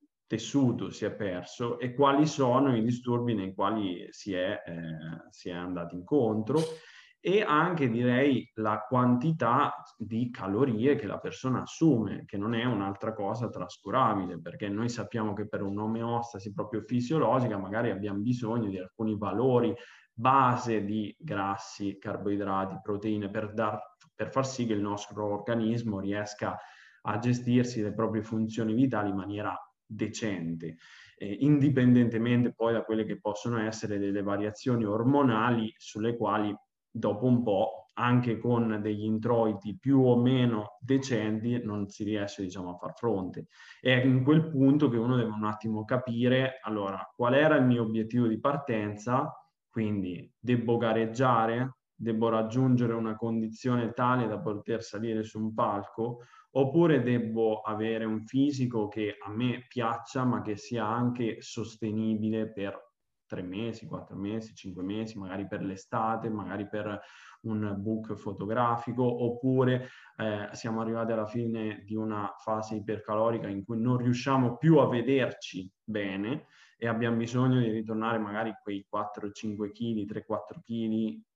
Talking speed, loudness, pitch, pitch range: 140 wpm, -30 LUFS, 110 Hz, 105-125 Hz